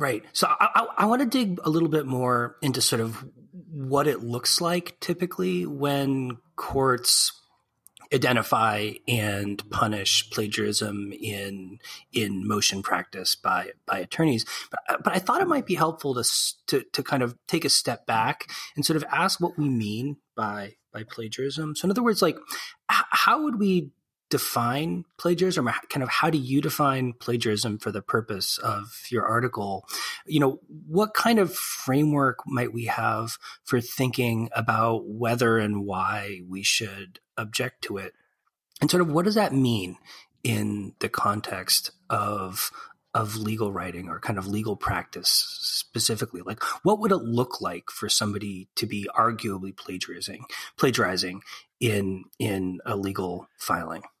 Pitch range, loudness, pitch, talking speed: 105-155 Hz, -25 LUFS, 120 Hz, 155 wpm